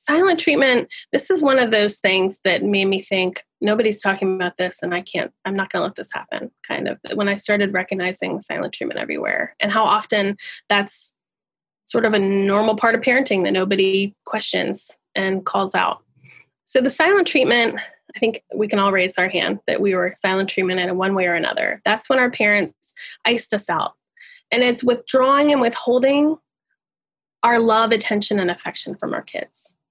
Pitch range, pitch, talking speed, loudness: 195-250 Hz, 210 Hz, 185 wpm, -19 LUFS